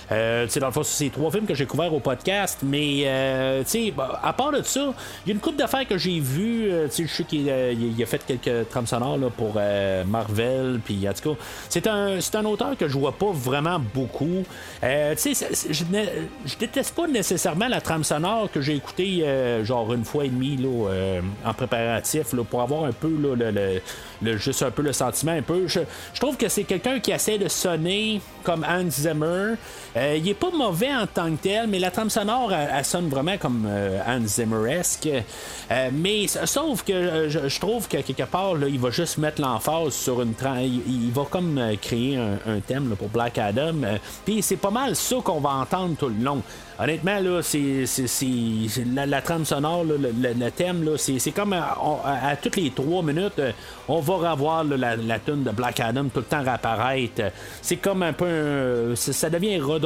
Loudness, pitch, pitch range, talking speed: -24 LUFS, 145 Hz, 125-180 Hz, 230 wpm